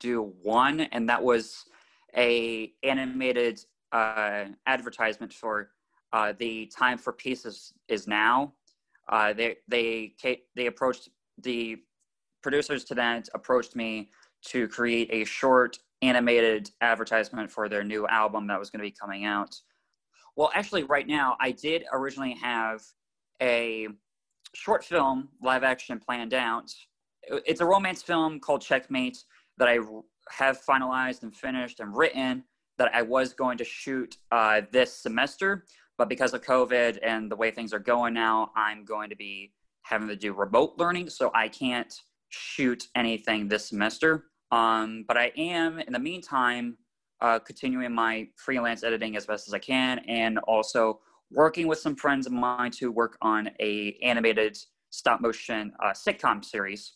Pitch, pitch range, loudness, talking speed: 120 Hz, 110-130 Hz, -27 LUFS, 155 wpm